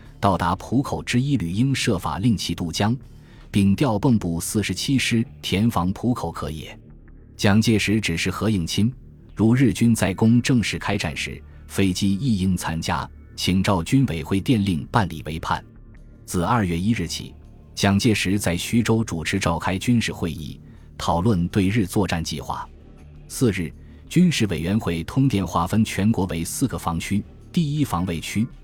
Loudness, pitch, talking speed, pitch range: -22 LUFS, 100 Hz, 240 characters per minute, 85-115 Hz